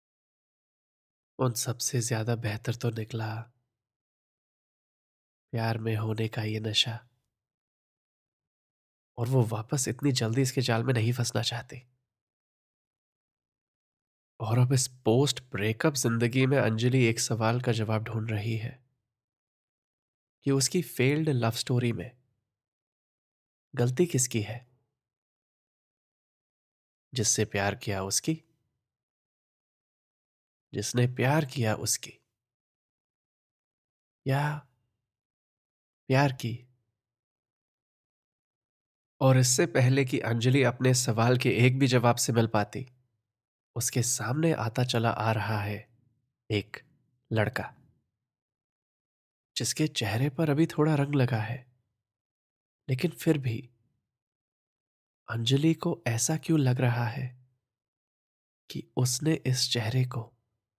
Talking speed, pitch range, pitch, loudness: 105 wpm, 115-130 Hz, 120 Hz, -28 LUFS